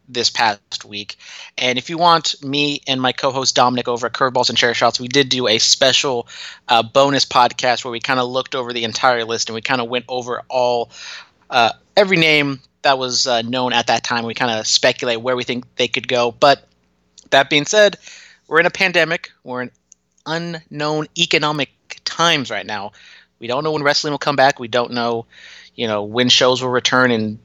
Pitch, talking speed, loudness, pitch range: 125 Hz, 210 wpm, -16 LUFS, 120-140 Hz